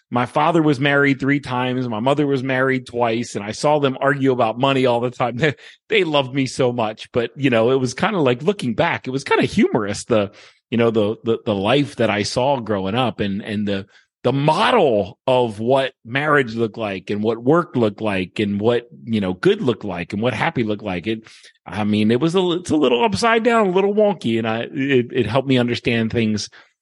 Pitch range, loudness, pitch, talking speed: 110-140 Hz, -19 LUFS, 125 Hz, 230 wpm